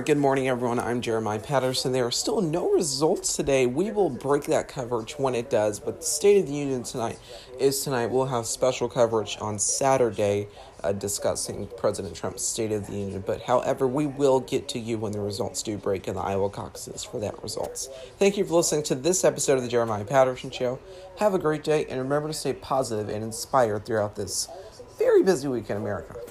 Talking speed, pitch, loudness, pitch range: 210 wpm, 130 Hz, -26 LUFS, 110-145 Hz